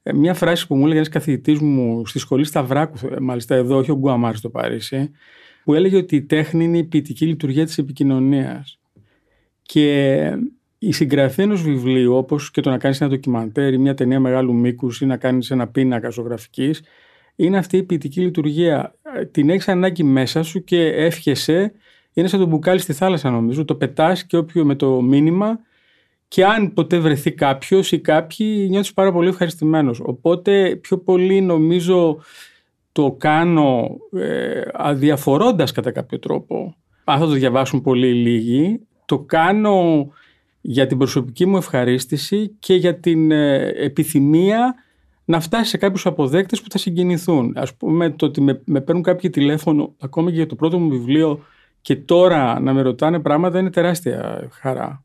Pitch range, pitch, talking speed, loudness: 135-180 Hz, 155 Hz, 165 wpm, -18 LUFS